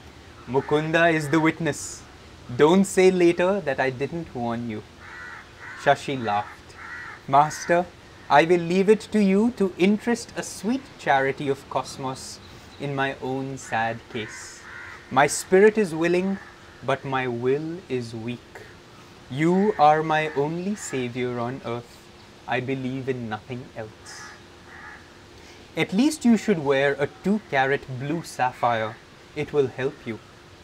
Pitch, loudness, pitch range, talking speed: 135 Hz, -23 LUFS, 120-170 Hz, 135 wpm